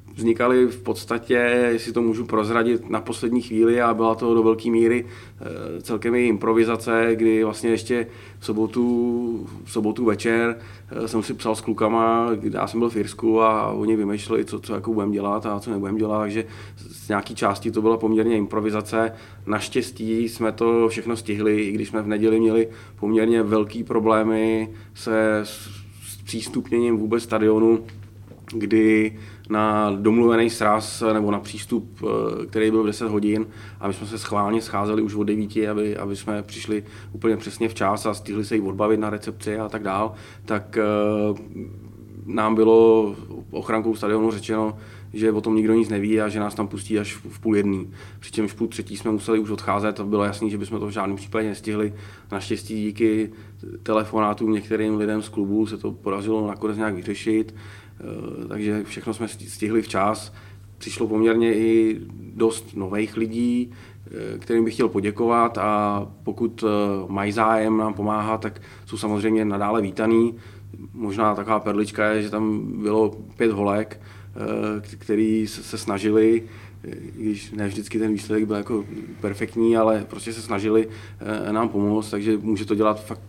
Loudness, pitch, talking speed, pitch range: -22 LUFS, 110 Hz, 160 wpm, 105-115 Hz